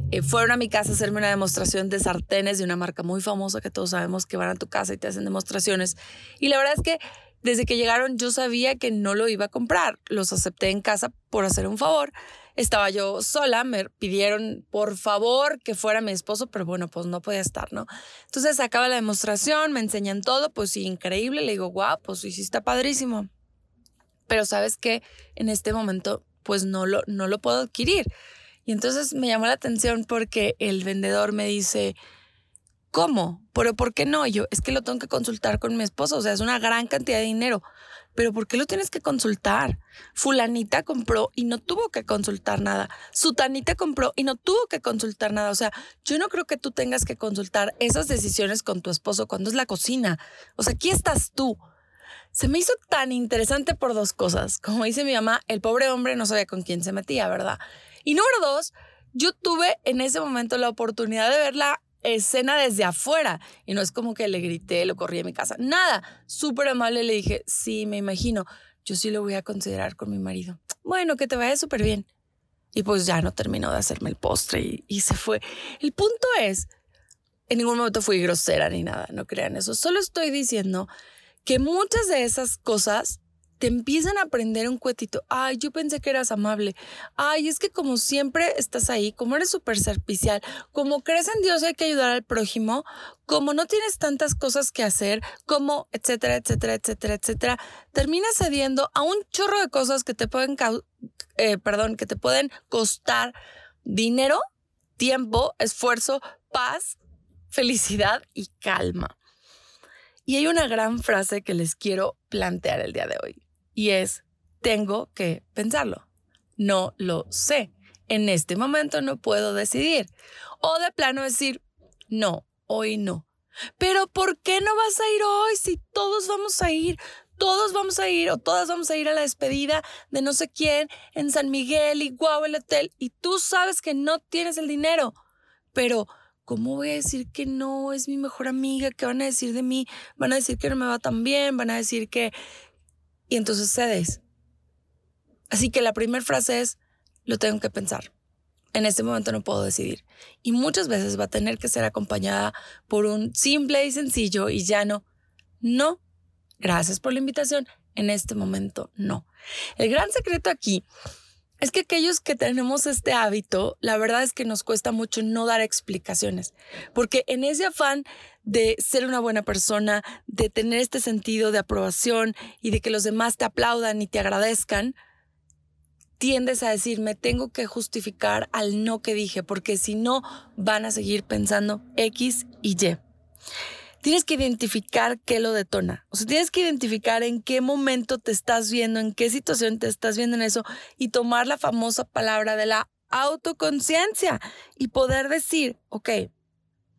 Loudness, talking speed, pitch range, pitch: -24 LUFS, 190 wpm, 205-280 Hz, 230 Hz